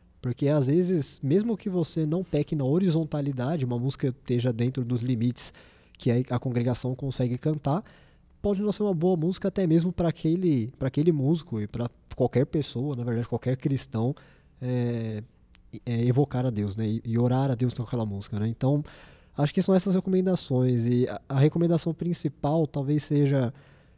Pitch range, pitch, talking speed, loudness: 120-160 Hz, 135 Hz, 175 wpm, -27 LUFS